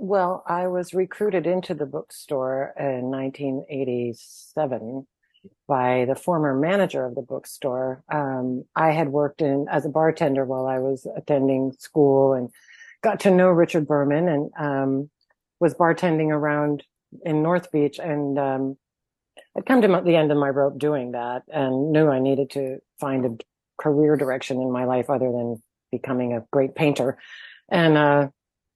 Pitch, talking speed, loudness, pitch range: 140 Hz, 155 wpm, -23 LUFS, 130-160 Hz